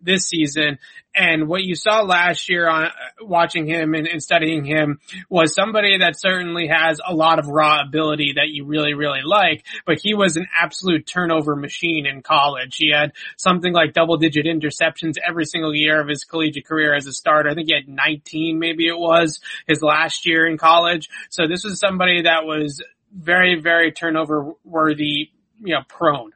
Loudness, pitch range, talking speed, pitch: -17 LUFS, 150-170 Hz, 190 wpm, 160 Hz